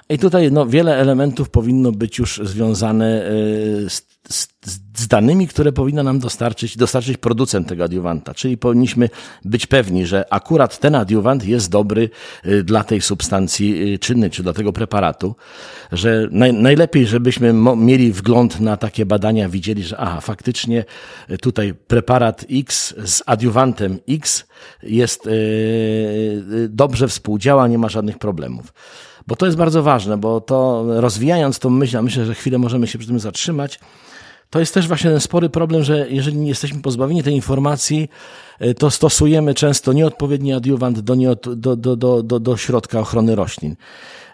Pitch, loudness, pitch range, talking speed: 120 Hz, -16 LUFS, 110-135 Hz, 155 wpm